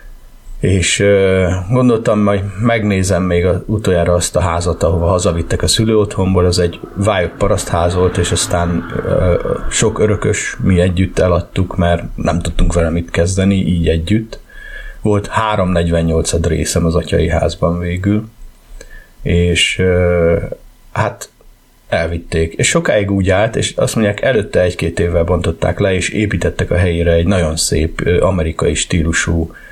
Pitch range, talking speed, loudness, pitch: 85-100 Hz, 135 wpm, -14 LUFS, 90 Hz